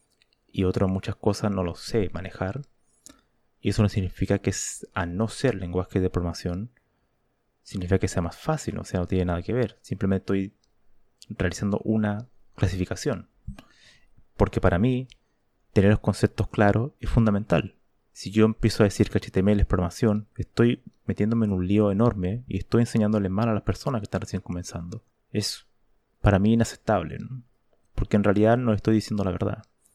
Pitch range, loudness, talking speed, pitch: 95-115 Hz, -25 LUFS, 170 wpm, 105 Hz